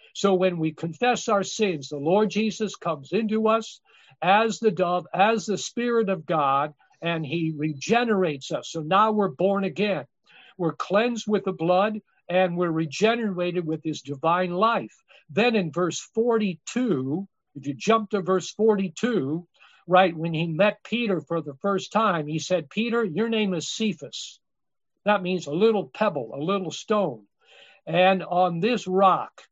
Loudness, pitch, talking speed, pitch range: -24 LUFS, 190 Hz, 160 wpm, 165-215 Hz